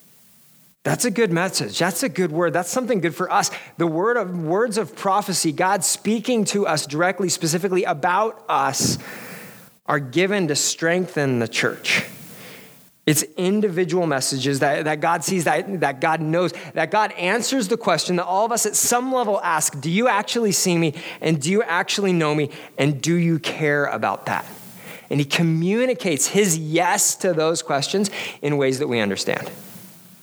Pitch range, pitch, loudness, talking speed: 155-200 Hz, 175 Hz, -21 LUFS, 175 wpm